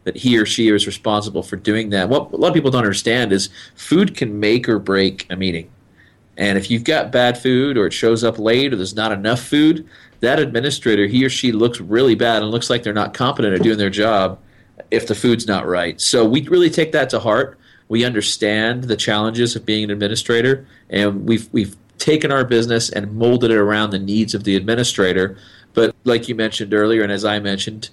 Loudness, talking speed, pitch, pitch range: -17 LUFS, 220 wpm, 110 Hz, 100-120 Hz